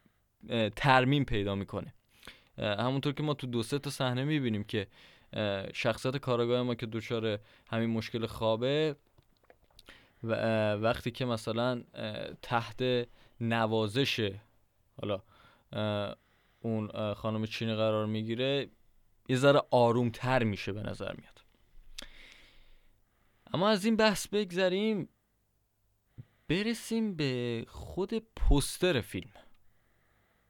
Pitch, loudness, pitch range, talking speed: 115 Hz, -32 LUFS, 110-130 Hz, 100 wpm